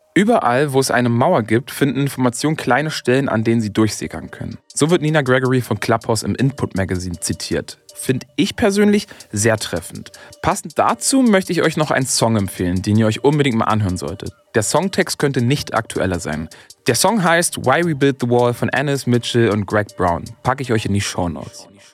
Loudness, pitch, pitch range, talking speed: -18 LUFS, 125 Hz, 110-145 Hz, 200 wpm